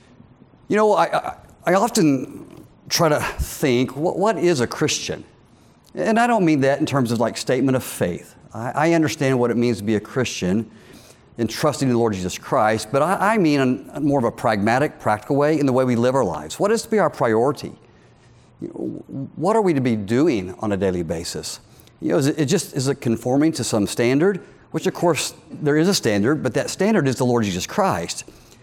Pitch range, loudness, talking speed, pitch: 115-155 Hz, -20 LUFS, 220 wpm, 130 Hz